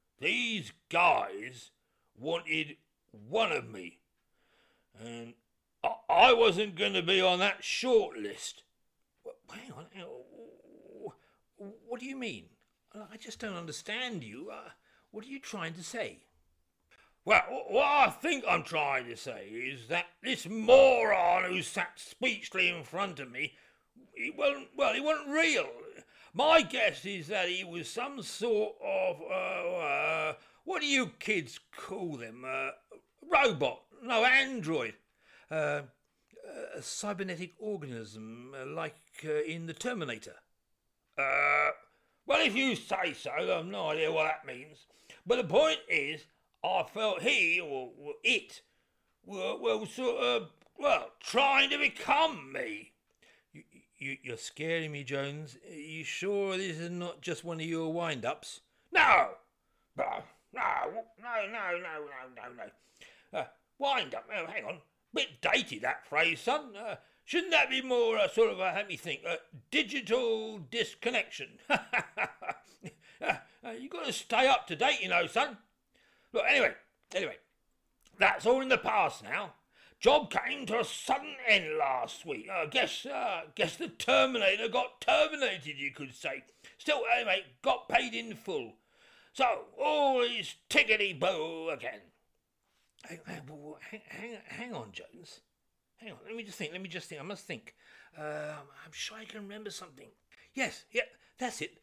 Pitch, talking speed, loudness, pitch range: 205 Hz, 145 wpm, -31 LUFS, 155-260 Hz